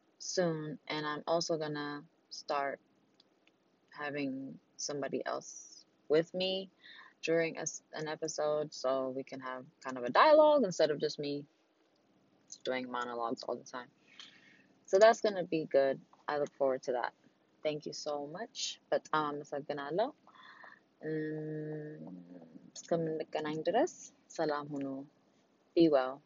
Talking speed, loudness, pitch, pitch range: 115 wpm, -34 LUFS, 150 Hz, 140-165 Hz